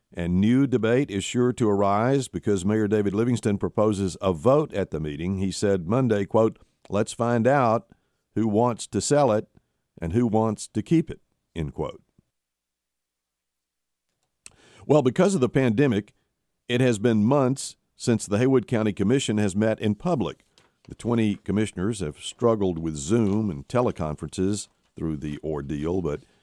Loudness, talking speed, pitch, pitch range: -24 LUFS, 155 wpm, 105 Hz, 85-120 Hz